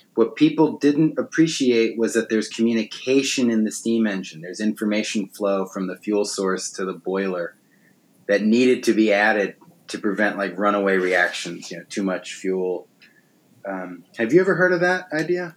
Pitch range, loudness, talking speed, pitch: 95-125 Hz, -21 LUFS, 175 wpm, 110 Hz